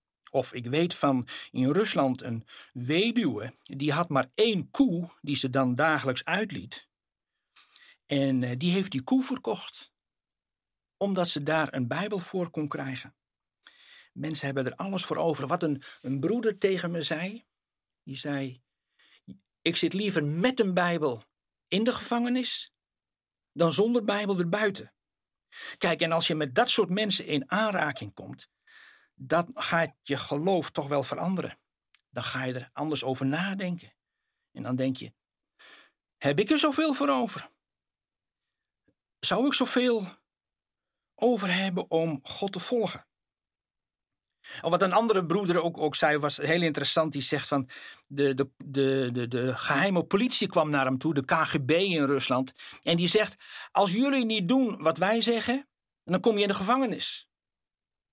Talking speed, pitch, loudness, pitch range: 155 wpm, 165 Hz, -28 LUFS, 140-205 Hz